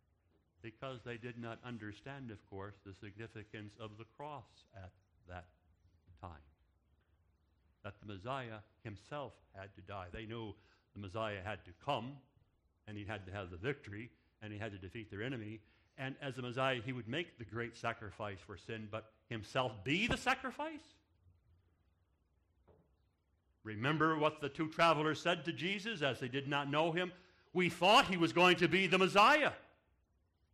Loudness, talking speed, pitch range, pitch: -36 LUFS, 165 wpm, 90-135 Hz, 110 Hz